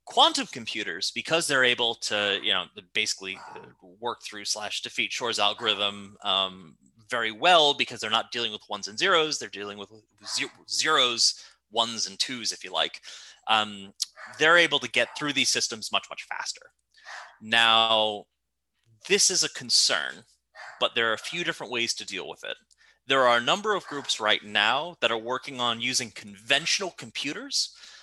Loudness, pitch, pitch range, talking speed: -25 LUFS, 120 Hz, 105-145 Hz, 165 wpm